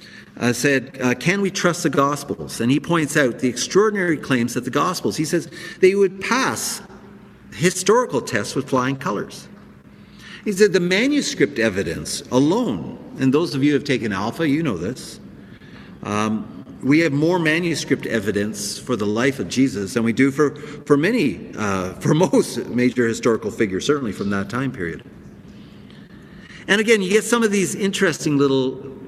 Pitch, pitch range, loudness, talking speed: 145 Hz, 125-180 Hz, -20 LUFS, 170 wpm